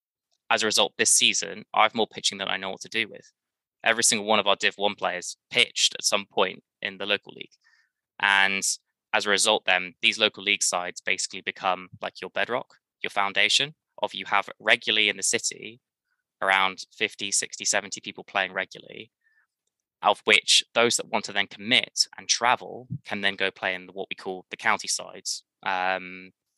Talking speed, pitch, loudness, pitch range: 190 wpm, 95 Hz, -24 LUFS, 95-105 Hz